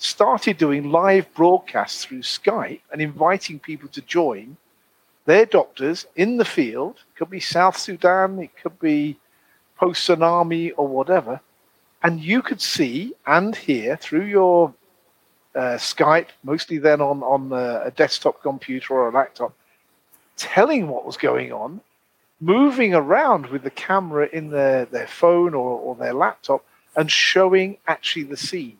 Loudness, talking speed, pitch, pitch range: -20 LUFS, 150 wpm, 170 Hz, 145-190 Hz